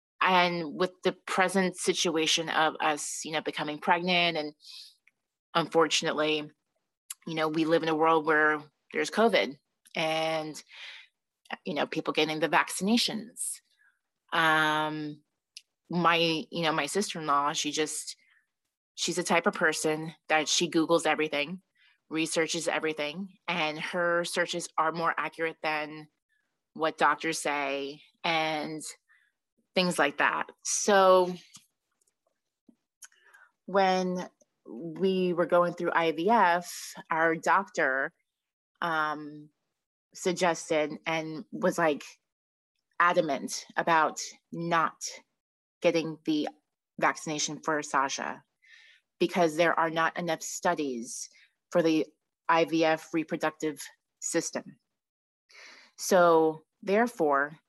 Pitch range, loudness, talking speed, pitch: 155-175 Hz, -28 LUFS, 100 wpm, 160 Hz